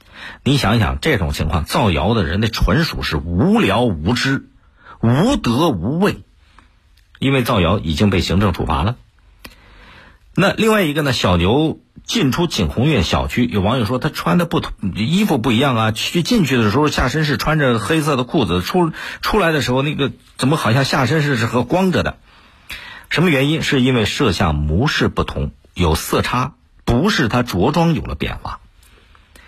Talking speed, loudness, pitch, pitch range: 260 characters per minute, -17 LUFS, 115 Hz, 90-140 Hz